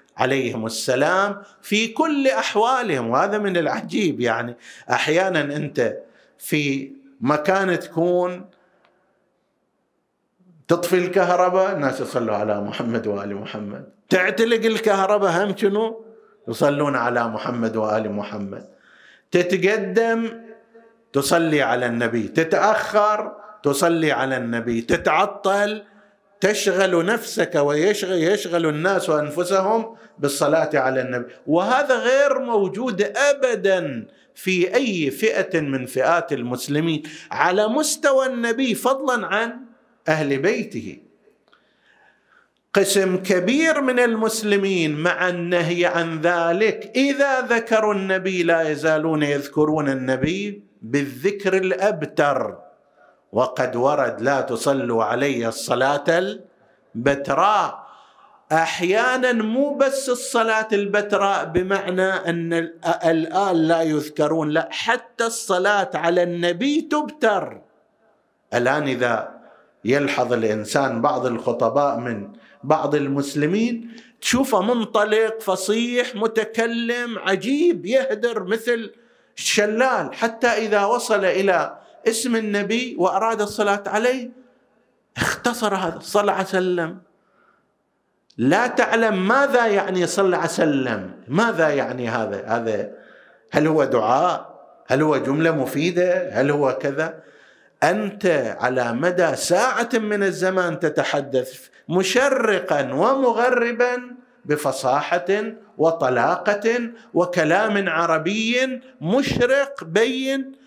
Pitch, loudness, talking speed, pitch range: 190 Hz, -20 LUFS, 95 wpm, 155-225 Hz